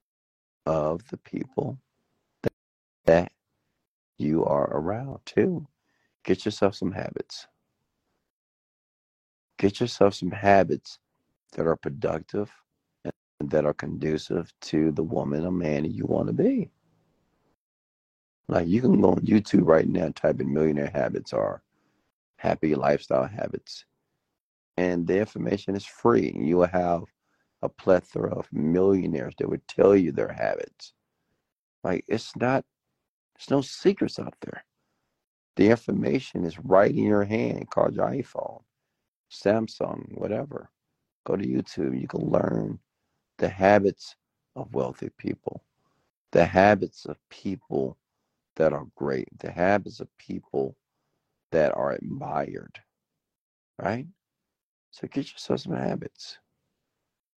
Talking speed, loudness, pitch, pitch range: 125 wpm, -26 LUFS, 90 Hz, 75-105 Hz